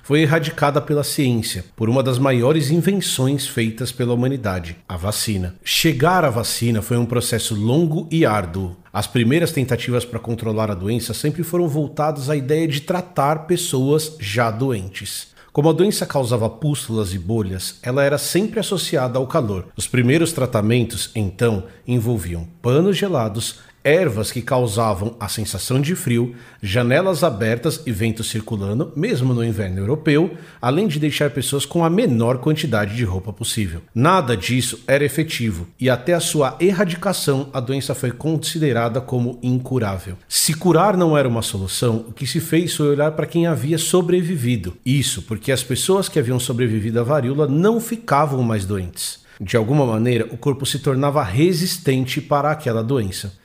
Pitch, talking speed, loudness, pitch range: 130 Hz, 160 wpm, -19 LUFS, 115-155 Hz